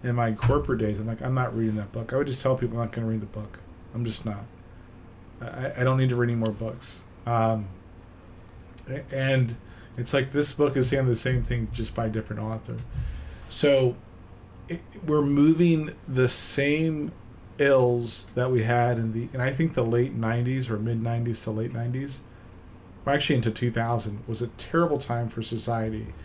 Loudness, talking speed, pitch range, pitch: -26 LUFS, 195 wpm, 110-130 Hz, 115 Hz